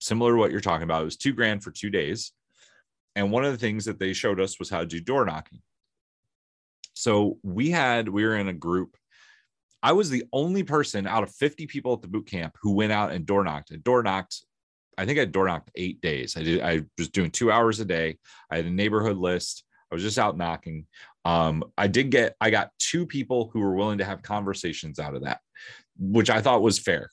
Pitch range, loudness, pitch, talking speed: 90-115 Hz, -26 LUFS, 100 Hz, 235 wpm